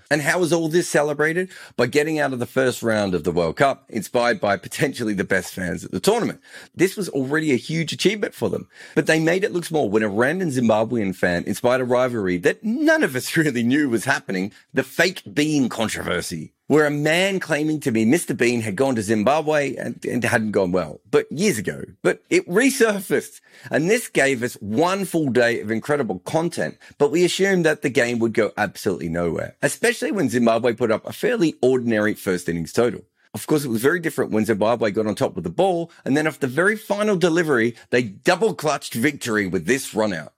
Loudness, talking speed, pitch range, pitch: -21 LUFS, 210 wpm, 115-165 Hz, 140 Hz